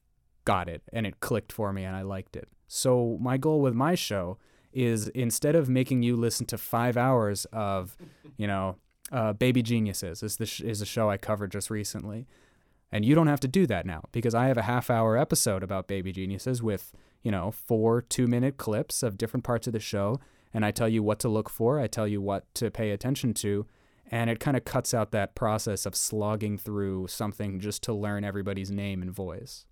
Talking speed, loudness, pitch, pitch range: 215 wpm, -29 LUFS, 110 Hz, 100-125 Hz